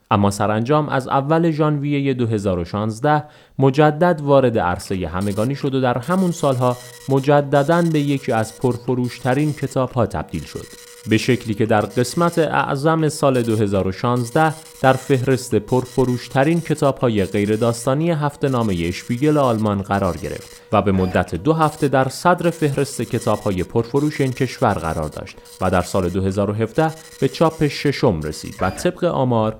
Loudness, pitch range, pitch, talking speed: -19 LUFS, 110-150 Hz, 130 Hz, 145 wpm